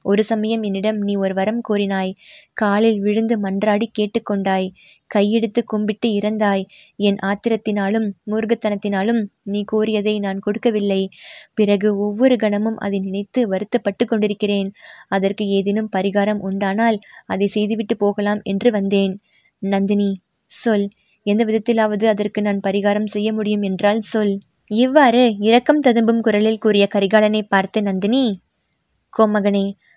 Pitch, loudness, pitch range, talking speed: 210 Hz, -19 LUFS, 200-220 Hz, 115 wpm